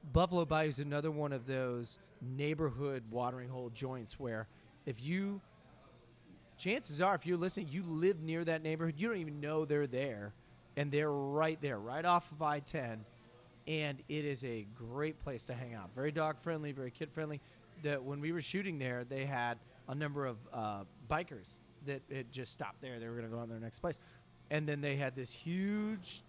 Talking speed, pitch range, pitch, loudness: 200 wpm, 125-155 Hz, 145 Hz, -39 LUFS